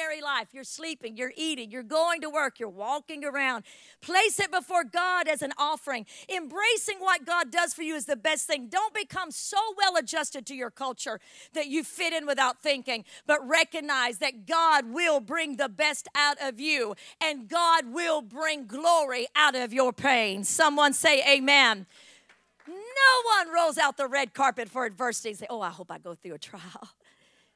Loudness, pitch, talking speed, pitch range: -26 LUFS, 290 Hz, 185 wpm, 255-330 Hz